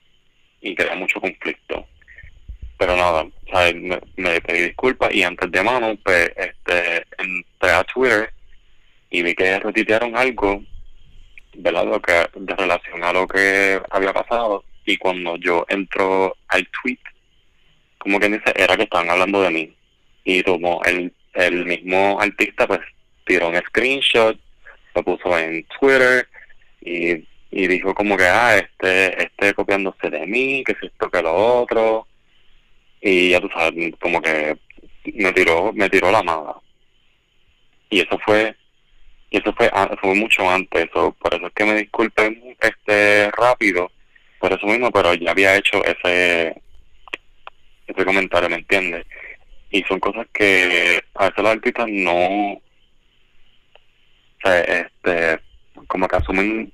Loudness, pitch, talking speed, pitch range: -18 LUFS, 95 Hz, 145 wpm, 90-105 Hz